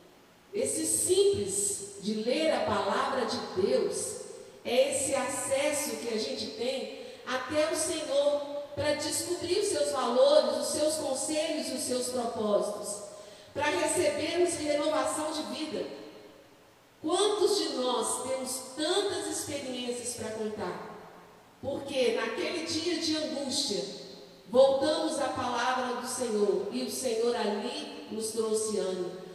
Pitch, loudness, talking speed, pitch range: 275 Hz, -30 LUFS, 120 wpm, 235-315 Hz